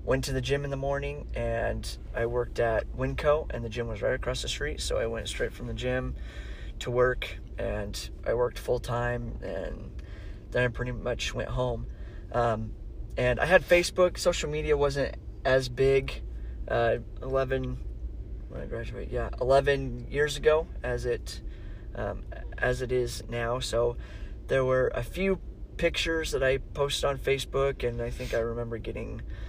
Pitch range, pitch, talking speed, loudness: 115-135 Hz, 125 Hz, 170 wpm, -29 LUFS